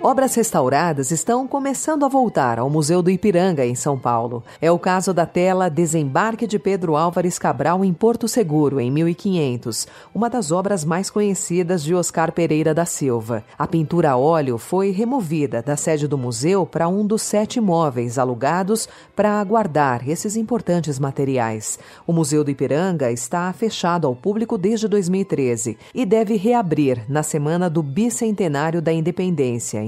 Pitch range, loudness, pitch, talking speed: 145-205 Hz, -20 LUFS, 170 Hz, 155 wpm